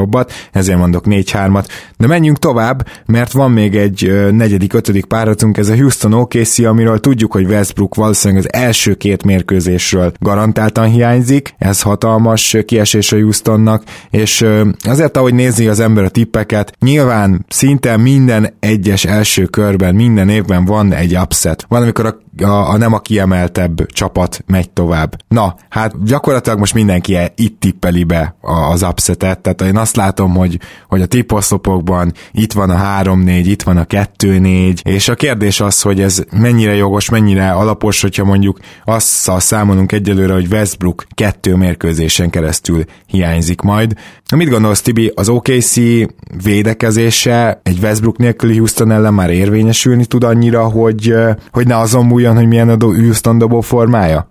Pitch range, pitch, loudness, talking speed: 95-115 Hz, 105 Hz, -11 LUFS, 155 wpm